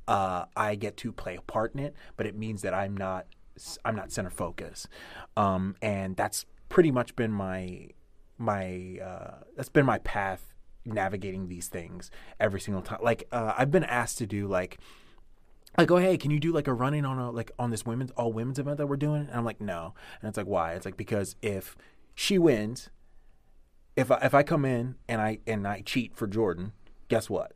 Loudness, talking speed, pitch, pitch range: -30 LUFS, 210 wpm, 110 Hz, 95-125 Hz